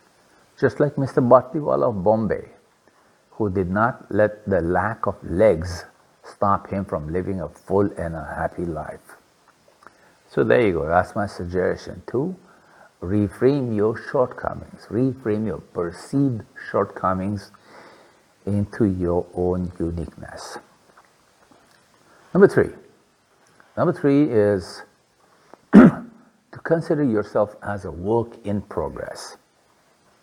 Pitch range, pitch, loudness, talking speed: 90-115 Hz, 105 Hz, -22 LUFS, 110 wpm